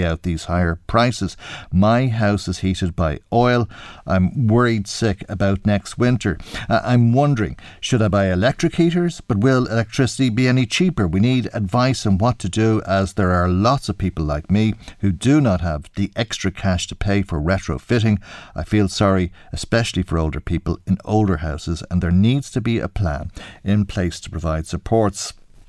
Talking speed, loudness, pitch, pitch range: 180 wpm, -19 LUFS, 100 Hz, 90-115 Hz